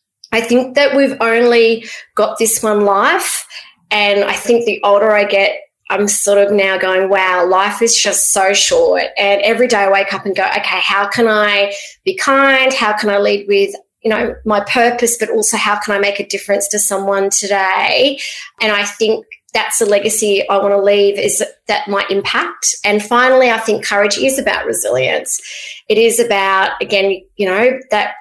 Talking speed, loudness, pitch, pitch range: 195 wpm, -13 LUFS, 210 Hz, 200-235 Hz